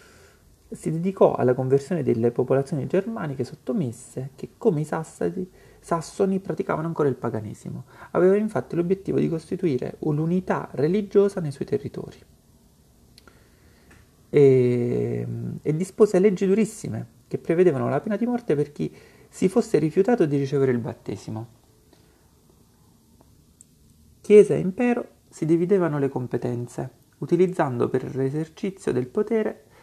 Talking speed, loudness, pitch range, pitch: 120 wpm, -23 LUFS, 125-190 Hz, 155 Hz